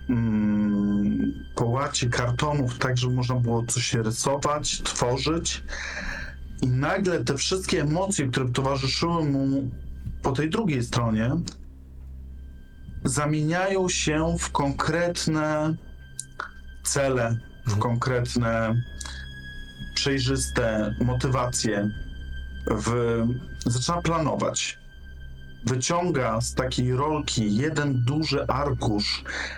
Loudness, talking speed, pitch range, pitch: -25 LUFS, 80 wpm, 100-140 Hz, 125 Hz